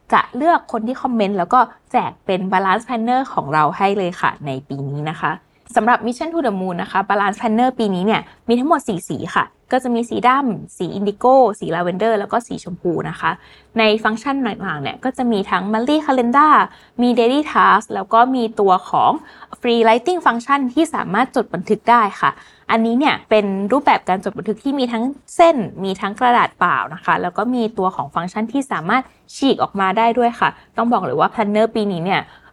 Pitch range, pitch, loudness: 195-250 Hz, 225 Hz, -17 LUFS